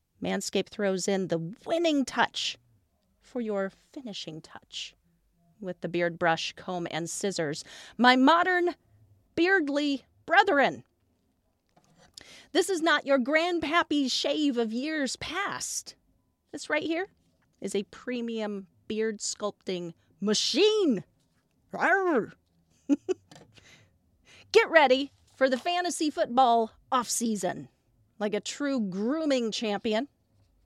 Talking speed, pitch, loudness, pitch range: 100 wpm, 230 Hz, -27 LUFS, 180-300 Hz